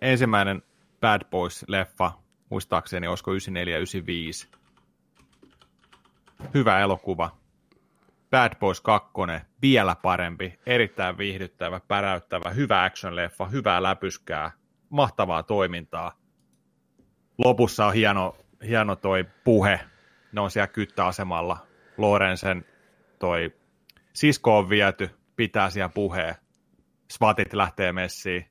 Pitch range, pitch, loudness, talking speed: 90-105 Hz, 95 Hz, -25 LUFS, 90 wpm